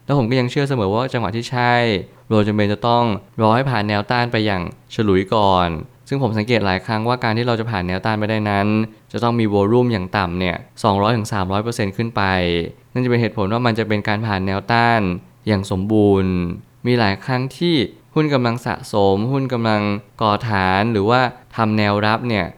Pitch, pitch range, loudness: 110 Hz, 100-120 Hz, -18 LUFS